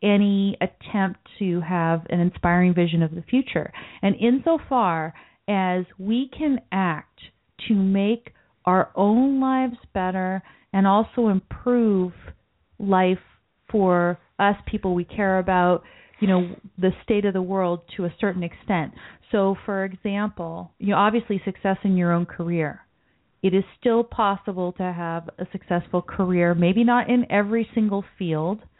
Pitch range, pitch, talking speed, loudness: 180-210 Hz, 195 Hz, 145 wpm, -23 LUFS